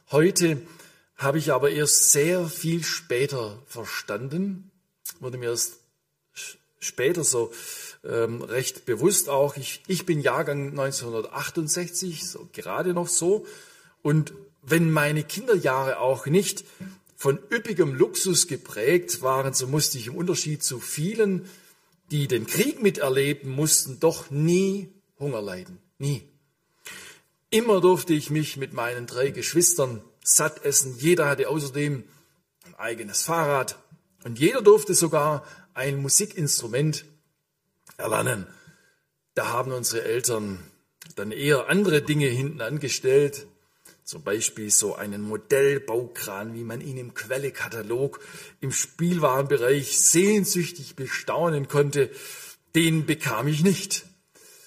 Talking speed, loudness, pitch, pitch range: 115 wpm, -24 LUFS, 150 Hz, 135-180 Hz